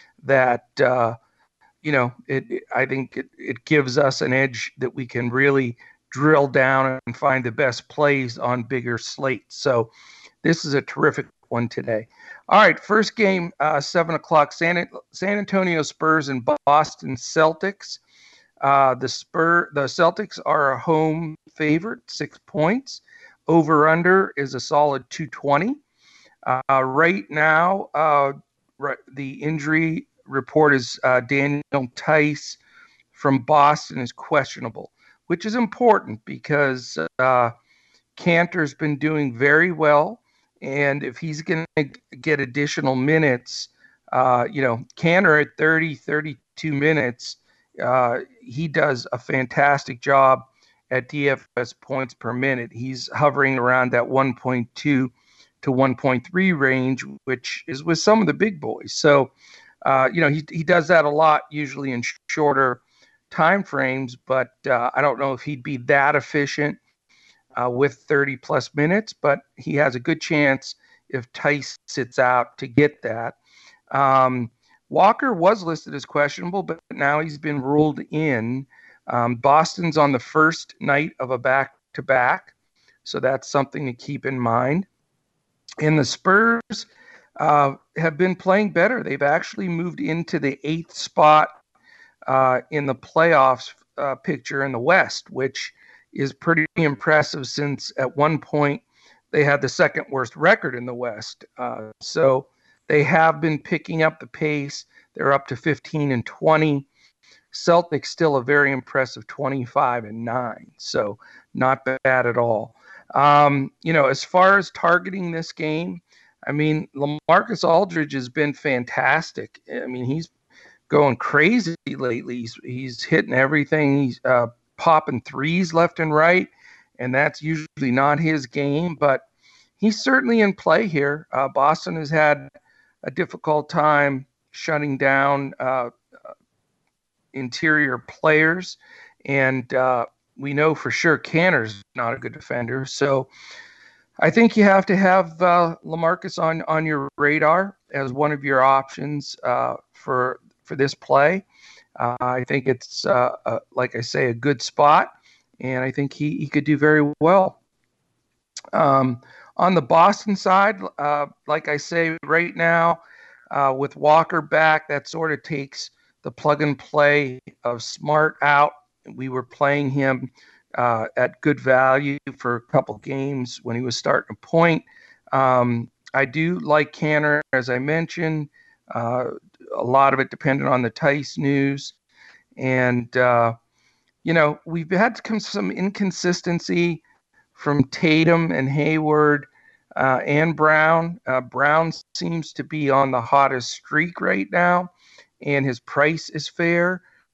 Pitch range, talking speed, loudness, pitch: 130-160 Hz, 145 wpm, -20 LUFS, 145 Hz